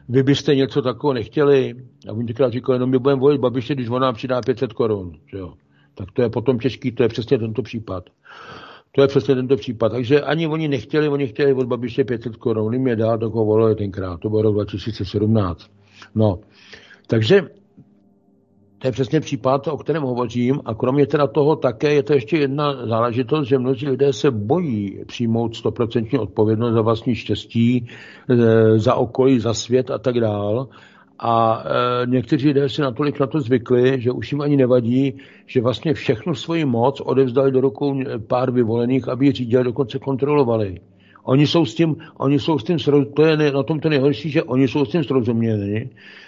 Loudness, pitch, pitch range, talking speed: -19 LUFS, 130 Hz, 115-140 Hz, 185 wpm